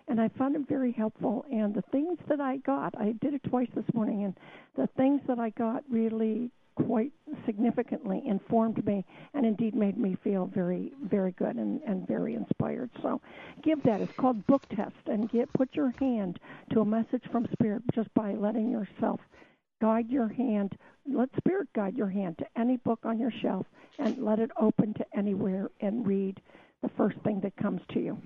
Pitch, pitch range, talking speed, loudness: 230 Hz, 210-255 Hz, 195 wpm, -31 LUFS